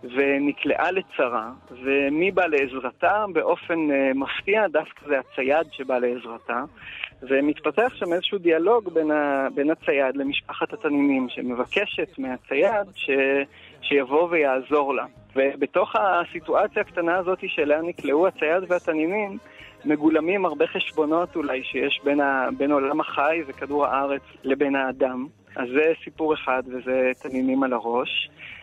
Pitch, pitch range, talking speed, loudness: 140 Hz, 130-165 Hz, 120 wpm, -23 LUFS